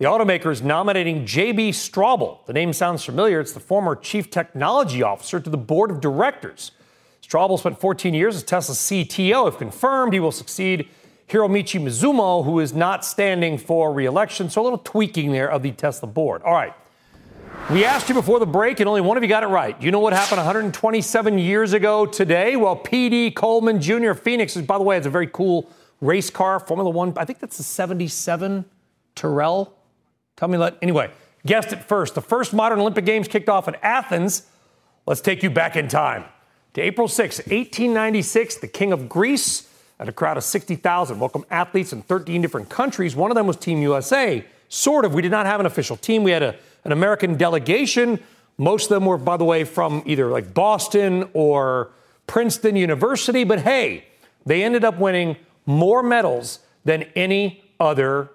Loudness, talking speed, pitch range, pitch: -20 LUFS, 190 wpm, 165-215 Hz, 185 Hz